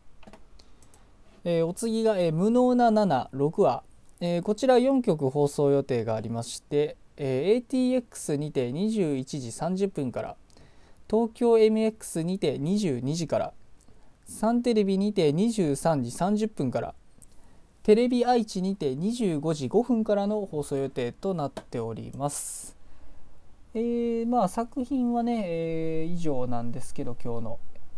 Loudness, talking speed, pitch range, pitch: -27 LUFS, 215 characters per minute, 135-220 Hz, 170 Hz